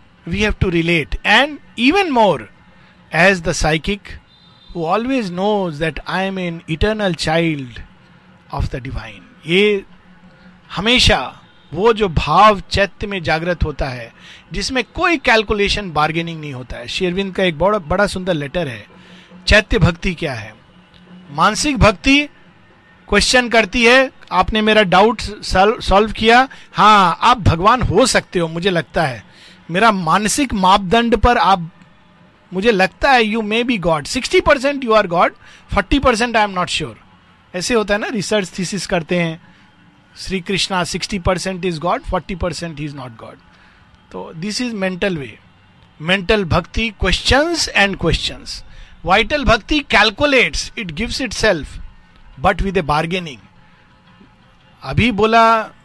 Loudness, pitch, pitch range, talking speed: -15 LUFS, 190 Hz, 165-220 Hz, 140 wpm